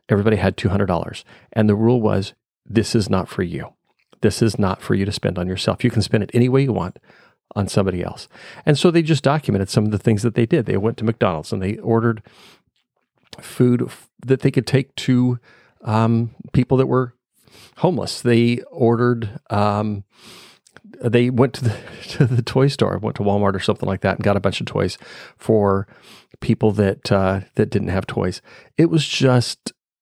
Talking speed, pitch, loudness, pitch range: 200 wpm, 115 Hz, -19 LUFS, 100-125 Hz